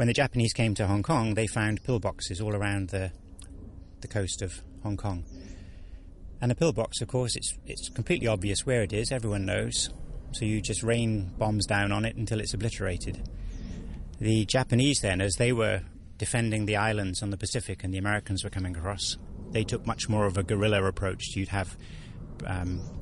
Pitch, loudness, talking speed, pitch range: 105 Hz, -29 LUFS, 190 wpm, 95-115 Hz